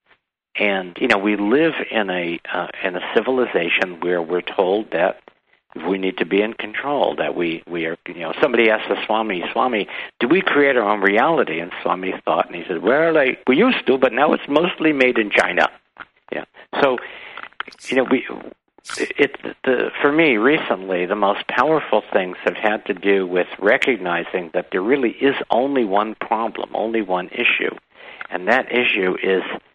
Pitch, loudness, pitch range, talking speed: 100 Hz, -19 LUFS, 90-120 Hz, 185 wpm